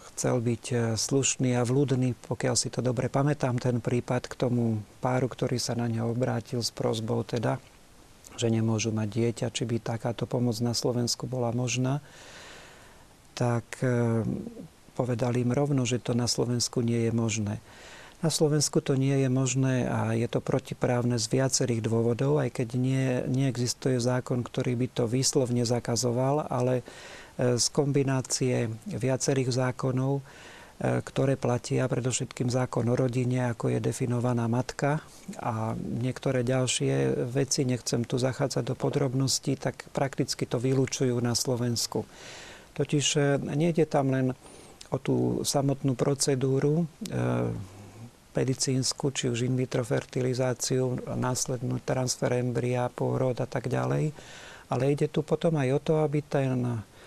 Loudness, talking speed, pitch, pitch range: -28 LUFS, 135 wpm, 125 Hz, 120-135 Hz